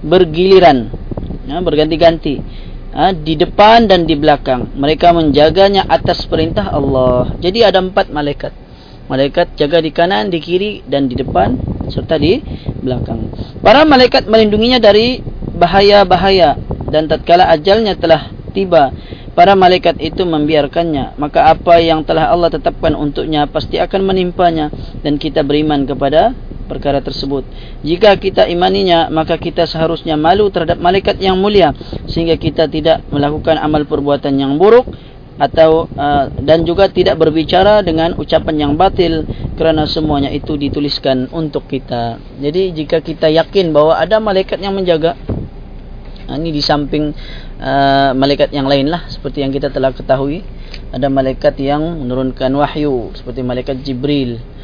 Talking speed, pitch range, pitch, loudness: 135 wpm, 140-175 Hz, 160 Hz, -12 LUFS